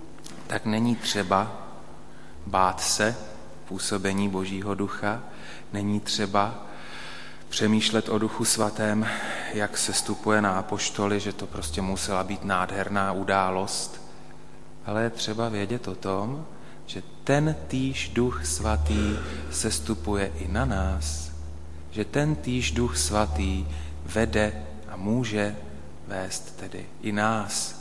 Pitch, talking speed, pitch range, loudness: 100 Hz, 115 wpm, 85-110 Hz, -27 LUFS